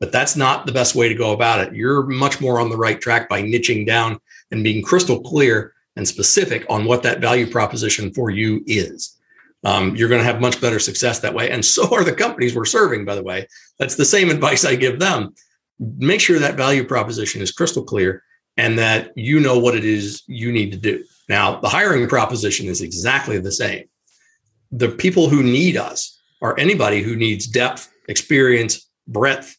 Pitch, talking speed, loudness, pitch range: 115 Hz, 205 wpm, -17 LUFS, 110-125 Hz